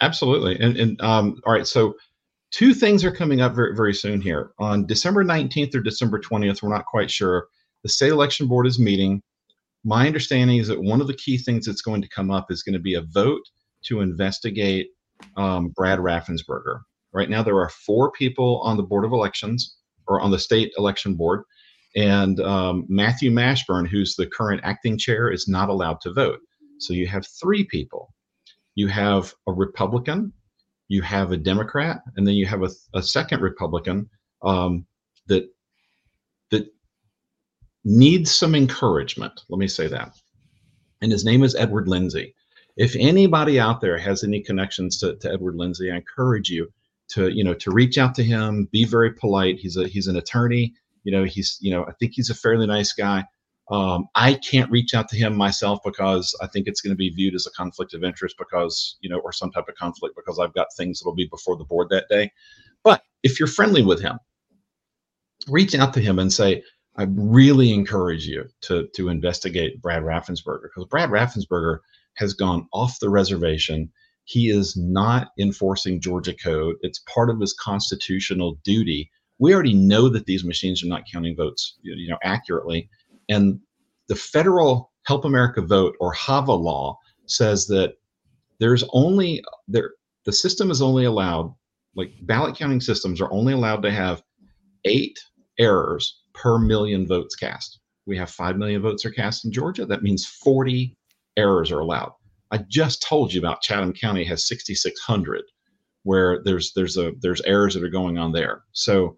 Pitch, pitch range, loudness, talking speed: 100 Hz, 95-120 Hz, -21 LUFS, 180 wpm